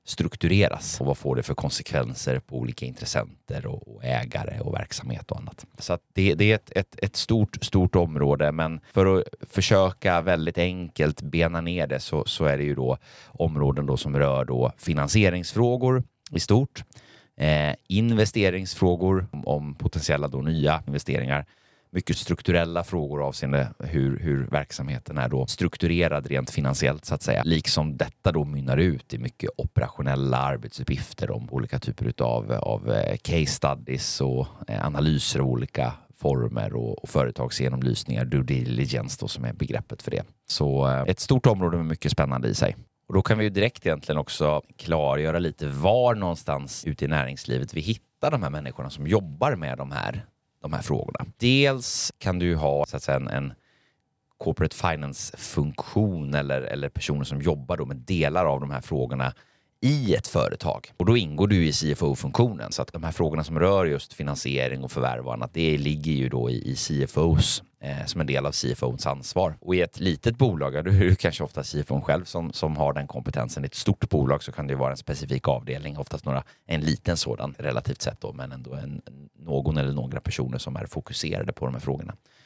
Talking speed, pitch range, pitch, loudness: 180 wpm, 70-90 Hz, 75 Hz, -26 LUFS